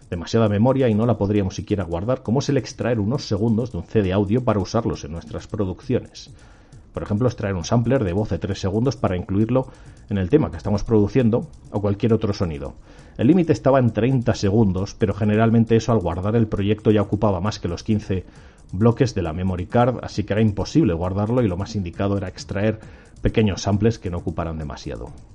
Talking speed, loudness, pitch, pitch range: 205 wpm, -21 LUFS, 105 Hz, 95-115 Hz